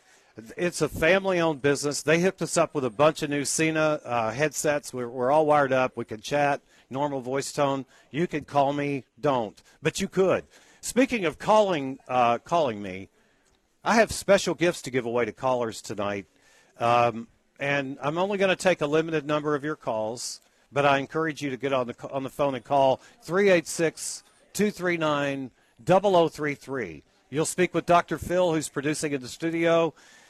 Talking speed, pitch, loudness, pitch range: 180 wpm, 145 Hz, -25 LUFS, 130-165 Hz